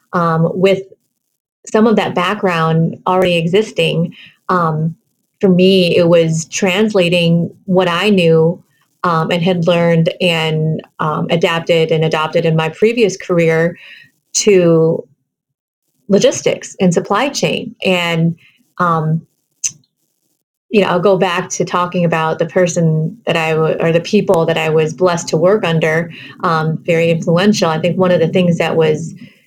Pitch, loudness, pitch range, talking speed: 175 Hz, -14 LUFS, 165-185 Hz, 140 wpm